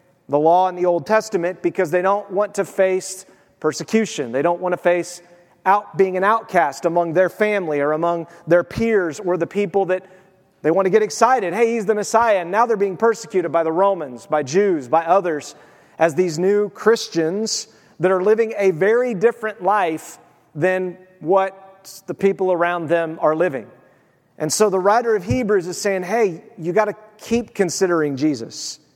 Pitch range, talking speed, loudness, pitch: 170-205 Hz, 180 wpm, -19 LUFS, 185 Hz